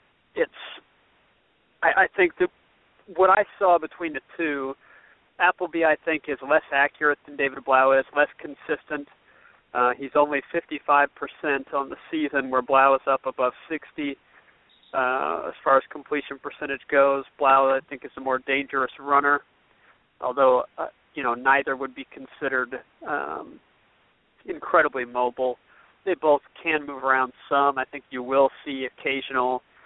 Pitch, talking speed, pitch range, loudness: 140 Hz, 155 wpm, 135-150 Hz, -24 LUFS